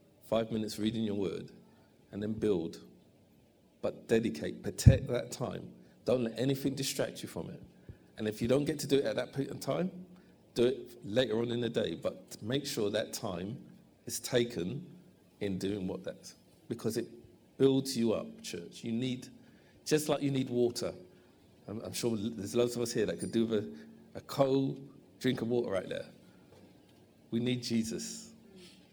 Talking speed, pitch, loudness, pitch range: 180 wpm, 120 Hz, -34 LUFS, 110-135 Hz